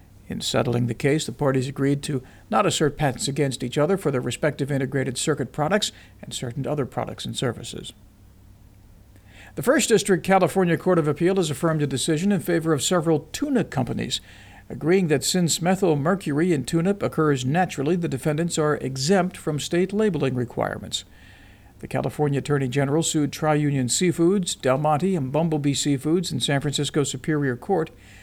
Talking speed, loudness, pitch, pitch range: 165 wpm, -23 LUFS, 150 Hz, 130-170 Hz